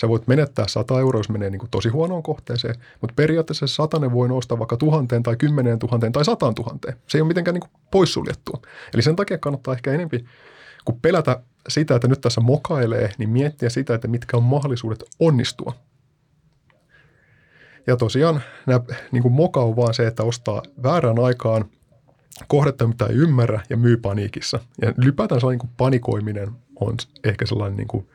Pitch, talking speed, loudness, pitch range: 125 Hz, 175 wpm, -21 LUFS, 115-145 Hz